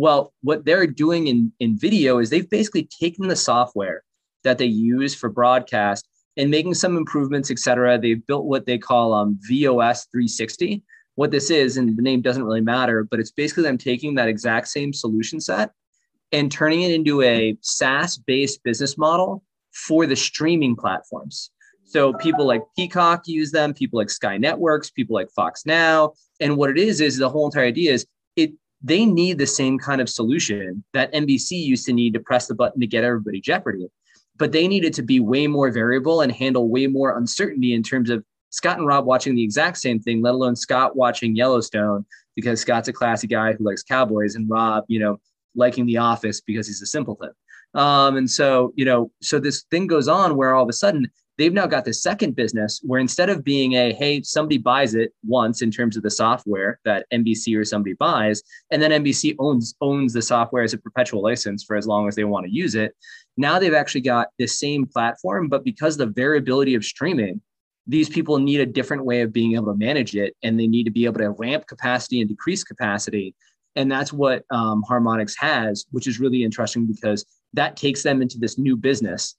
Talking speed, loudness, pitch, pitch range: 205 wpm, -20 LUFS, 125 Hz, 115-145 Hz